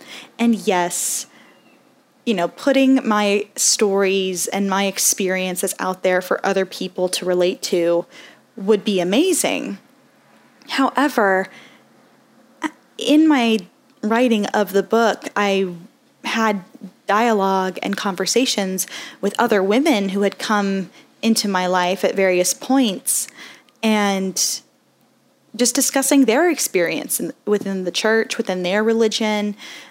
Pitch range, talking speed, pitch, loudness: 195-260 Hz, 110 wpm, 215 Hz, -19 LUFS